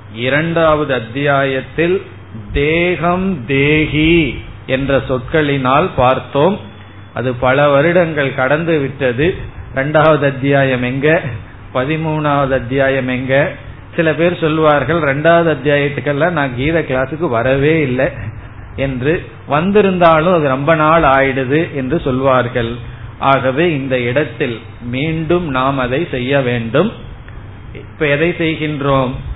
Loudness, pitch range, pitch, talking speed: -14 LUFS, 125-155 Hz, 135 Hz, 95 wpm